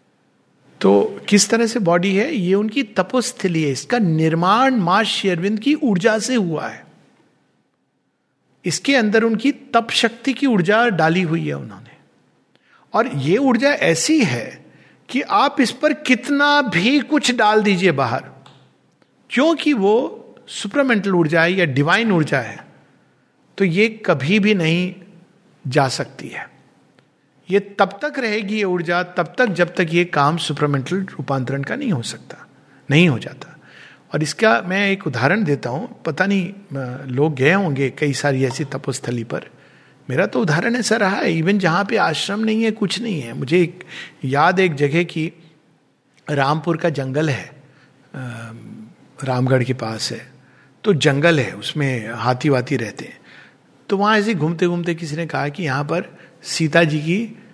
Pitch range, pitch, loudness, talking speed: 145-215 Hz, 175 Hz, -18 LUFS, 155 wpm